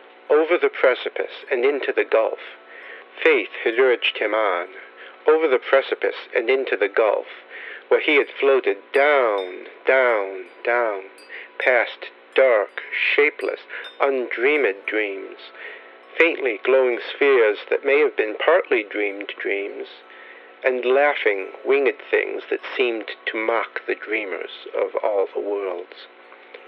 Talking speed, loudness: 125 wpm, -21 LUFS